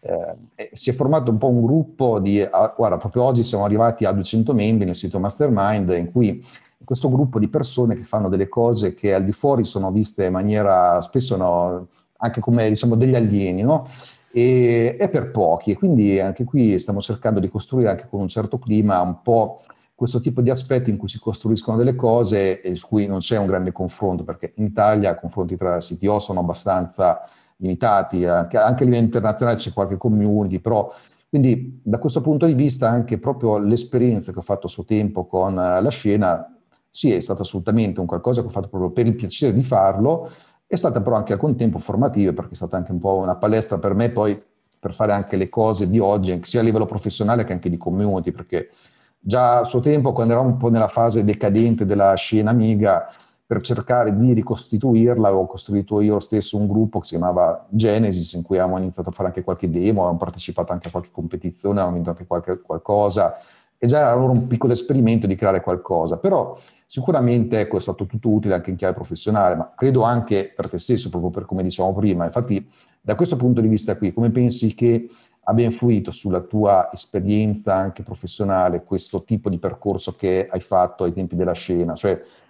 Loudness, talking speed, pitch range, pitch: -20 LUFS, 205 wpm, 95-120 Hz, 105 Hz